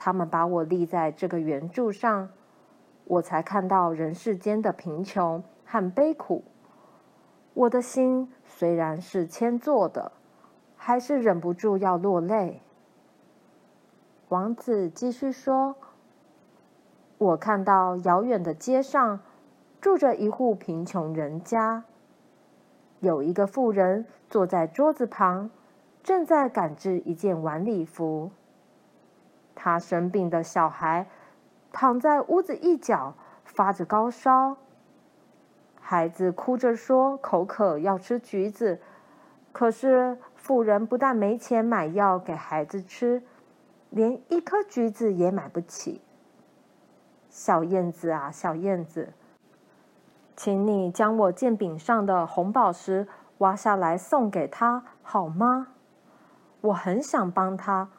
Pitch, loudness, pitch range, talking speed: 205 Hz, -26 LUFS, 175-245 Hz, 170 characters per minute